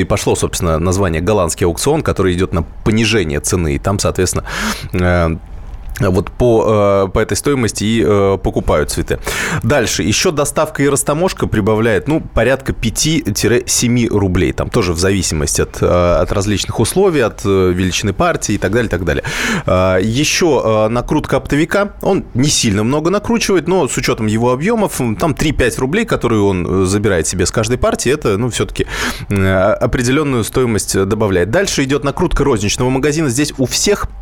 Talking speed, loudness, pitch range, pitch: 150 wpm, -14 LUFS, 95-135 Hz, 110 Hz